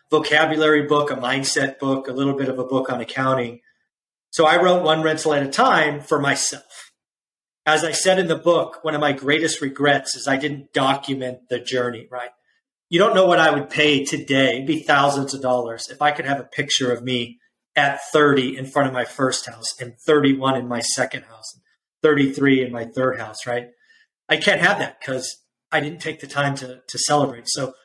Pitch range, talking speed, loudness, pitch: 130-150 Hz, 210 wpm, -20 LUFS, 140 Hz